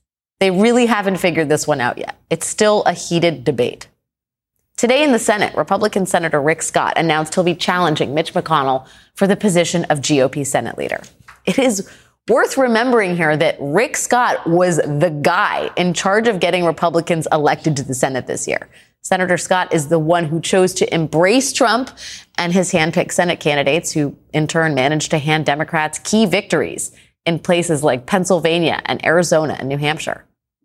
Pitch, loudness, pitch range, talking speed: 170 Hz, -16 LUFS, 155-190 Hz, 175 wpm